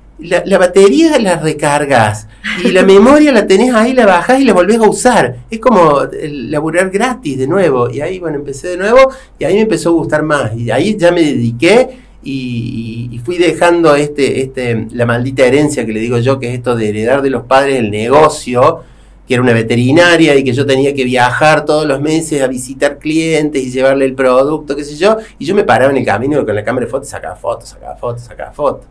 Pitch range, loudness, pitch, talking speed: 125-180 Hz, -11 LUFS, 145 Hz, 225 wpm